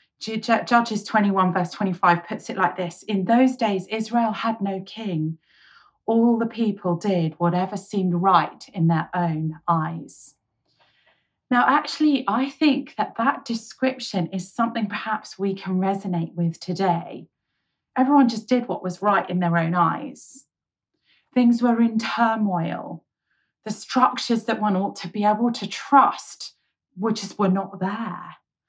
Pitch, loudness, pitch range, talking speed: 210 Hz, -22 LUFS, 185-230 Hz, 145 wpm